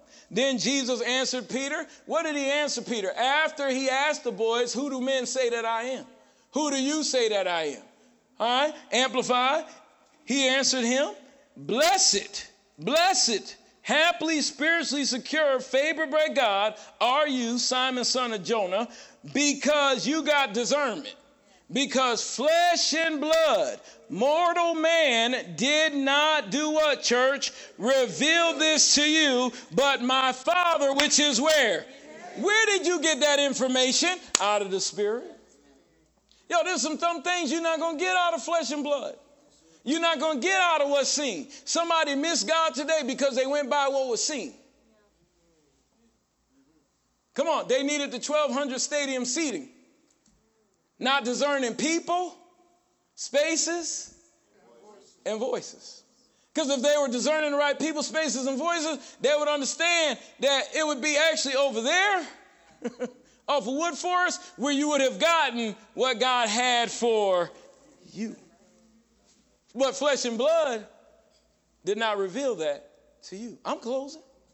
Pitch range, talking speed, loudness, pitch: 250-315 Hz, 145 wpm, -25 LUFS, 280 Hz